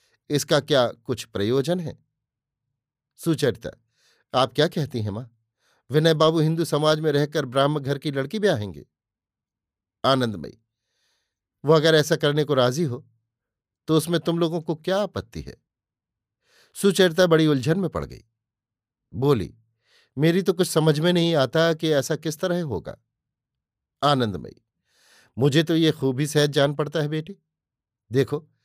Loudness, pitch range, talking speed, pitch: -22 LUFS, 130-165 Hz, 145 wpm, 150 Hz